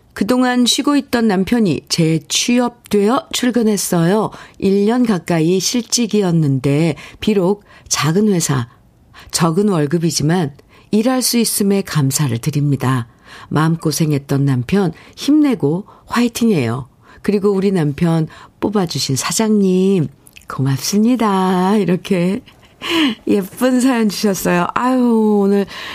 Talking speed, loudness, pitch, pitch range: 245 characters per minute, -16 LUFS, 195 Hz, 155-225 Hz